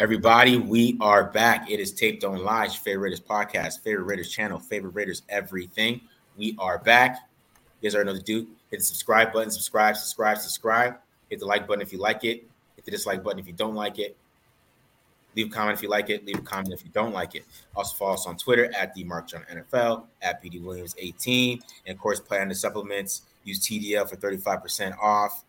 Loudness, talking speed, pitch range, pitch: -25 LUFS, 220 wpm, 100-115 Hz, 105 Hz